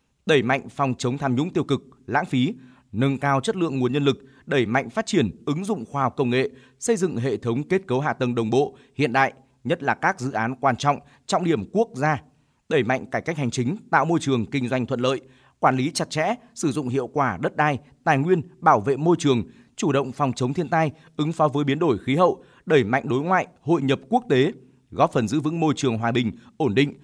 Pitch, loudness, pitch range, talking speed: 135 Hz, -23 LUFS, 130-155 Hz, 245 wpm